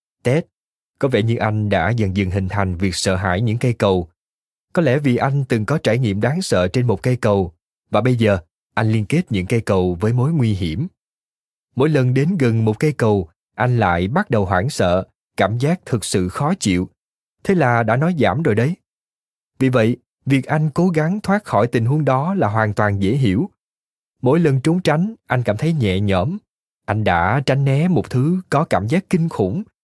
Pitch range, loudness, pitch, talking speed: 100-145 Hz, -18 LUFS, 120 Hz, 210 wpm